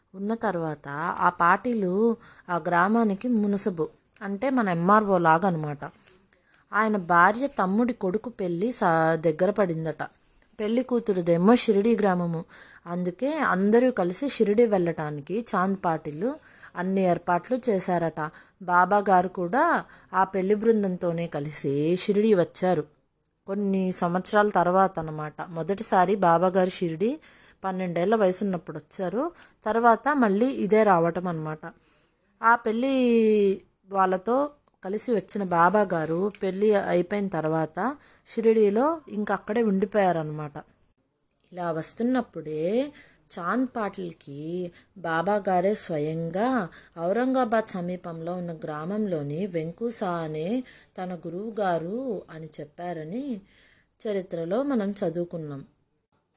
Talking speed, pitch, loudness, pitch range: 95 wpm, 190 Hz, -24 LUFS, 170-220 Hz